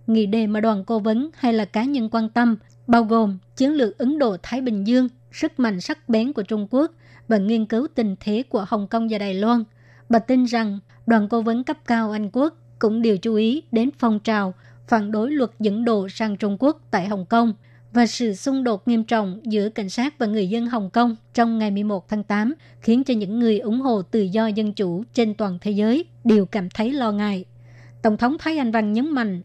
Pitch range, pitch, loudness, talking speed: 210-240 Hz, 225 Hz, -21 LUFS, 225 wpm